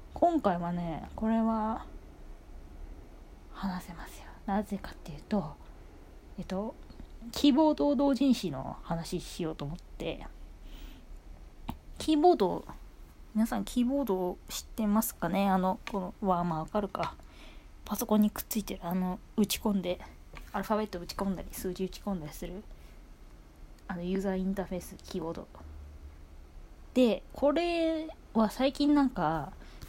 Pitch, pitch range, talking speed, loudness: 190 Hz, 155-220 Hz, 285 characters per minute, -31 LUFS